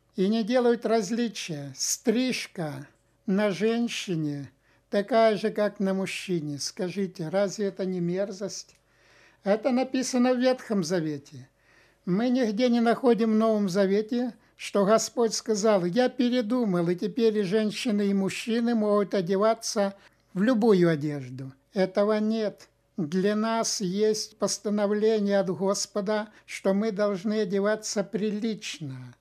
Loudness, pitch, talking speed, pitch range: -26 LUFS, 205 Hz, 120 wpm, 190-225 Hz